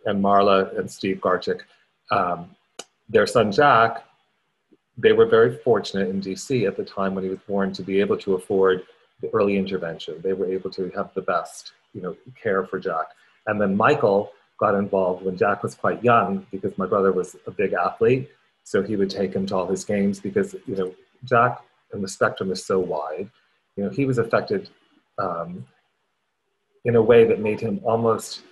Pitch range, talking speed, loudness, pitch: 95-115 Hz, 195 wpm, -22 LUFS, 100 Hz